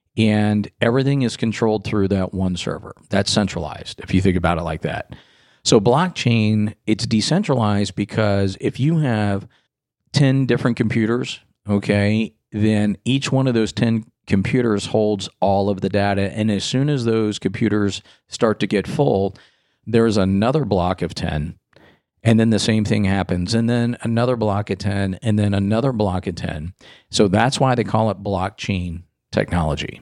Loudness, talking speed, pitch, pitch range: -19 LUFS, 165 wpm, 105 Hz, 100-115 Hz